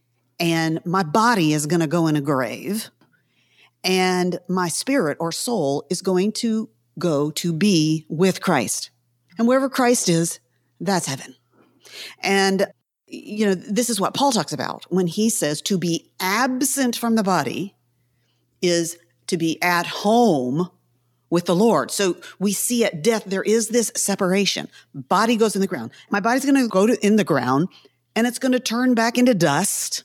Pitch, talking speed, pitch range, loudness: 185 Hz, 170 wpm, 155-225 Hz, -21 LUFS